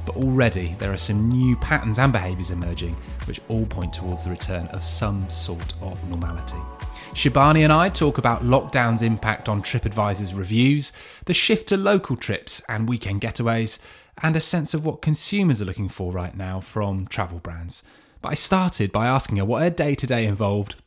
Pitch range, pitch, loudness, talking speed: 90-135 Hz, 110 Hz, -22 LUFS, 185 wpm